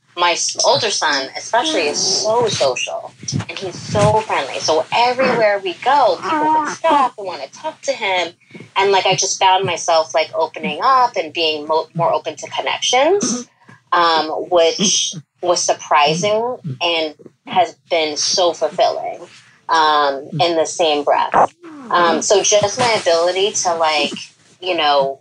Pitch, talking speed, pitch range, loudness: 180 Hz, 150 wpm, 160-220 Hz, -16 LUFS